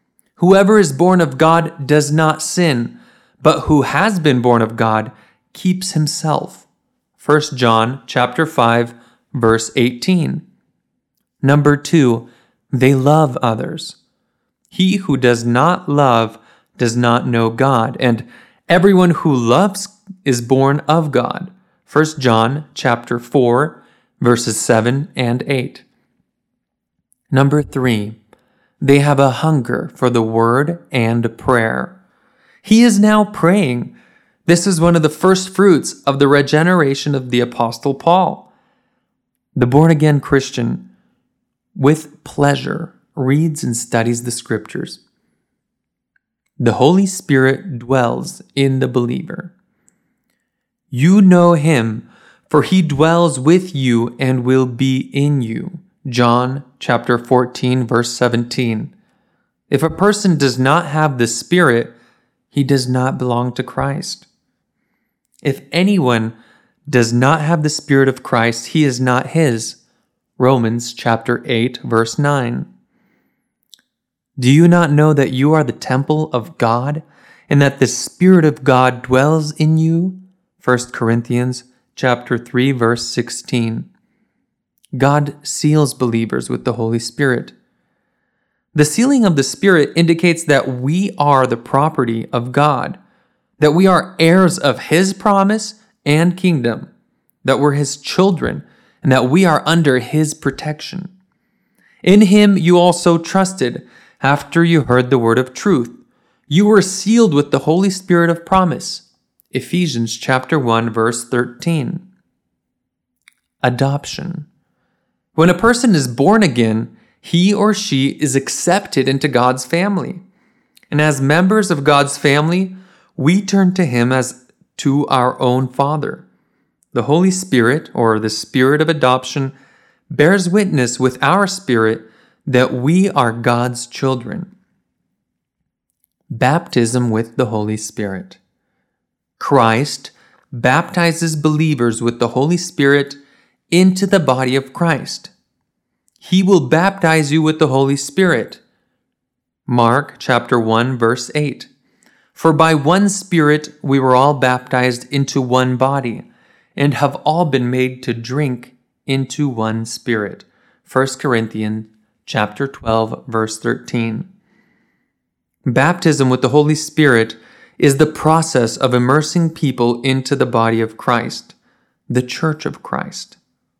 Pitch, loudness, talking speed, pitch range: 140 Hz, -15 LUFS, 125 wpm, 125-170 Hz